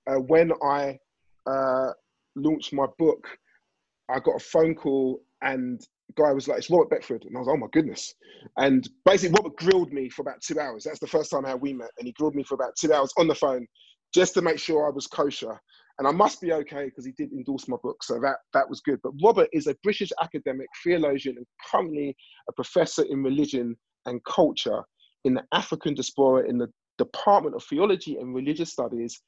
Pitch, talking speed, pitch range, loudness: 150 Hz, 215 wpm, 135-210 Hz, -25 LUFS